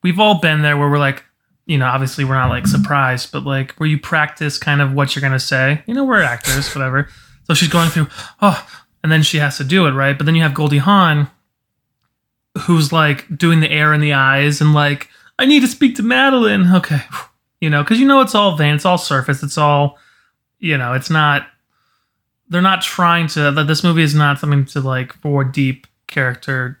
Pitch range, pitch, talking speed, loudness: 135-170 Hz, 145 Hz, 220 wpm, -14 LUFS